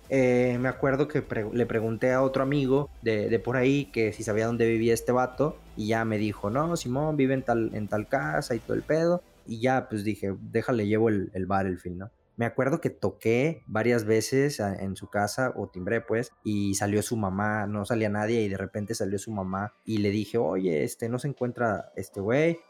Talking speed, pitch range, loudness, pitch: 220 wpm, 105-130 Hz, -27 LUFS, 115 Hz